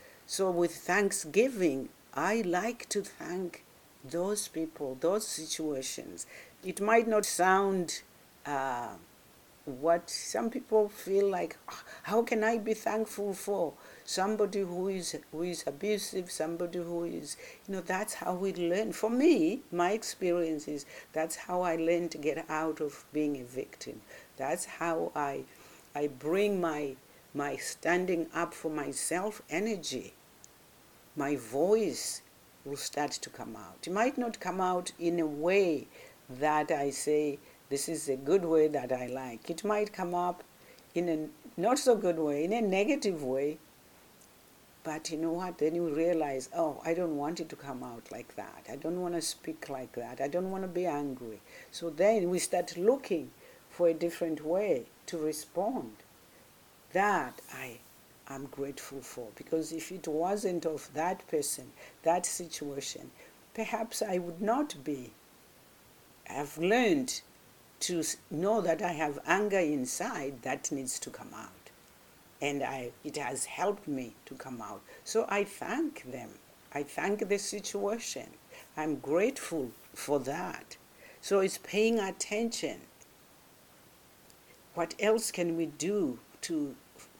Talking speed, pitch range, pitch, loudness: 145 wpm, 150-200 Hz, 170 Hz, -33 LUFS